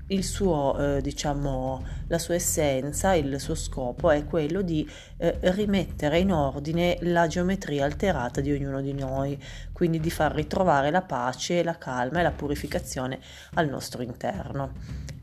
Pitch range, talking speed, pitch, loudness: 135-175 Hz, 150 wpm, 150 Hz, -27 LUFS